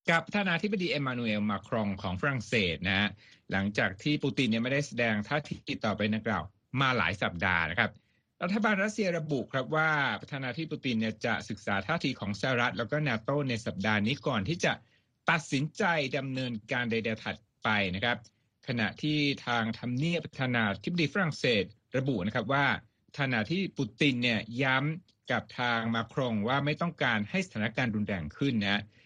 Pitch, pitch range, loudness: 125 Hz, 110-150 Hz, -30 LUFS